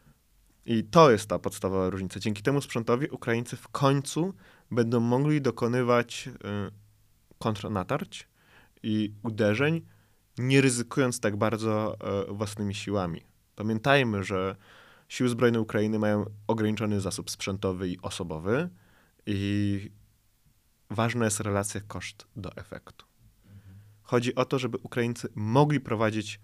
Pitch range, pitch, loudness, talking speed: 100-120 Hz, 110 Hz, -28 LUFS, 110 wpm